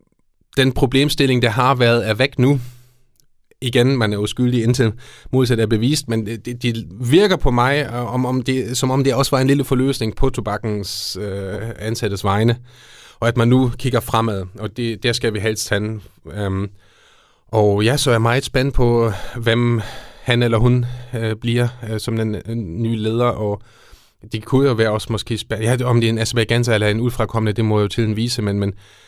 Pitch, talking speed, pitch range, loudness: 115 Hz, 200 wpm, 110-125 Hz, -18 LUFS